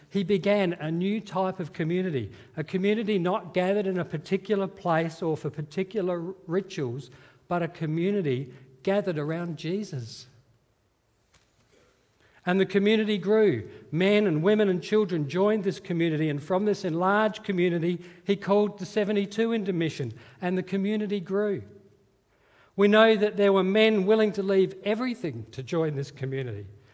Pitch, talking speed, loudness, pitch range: 185 Hz, 145 wpm, -26 LUFS, 150-200 Hz